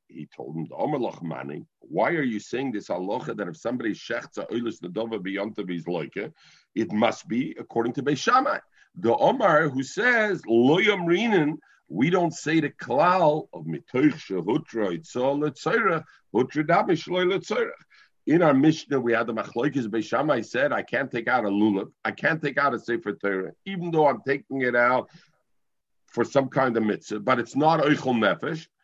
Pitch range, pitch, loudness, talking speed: 110-155 Hz, 130 Hz, -25 LUFS, 155 wpm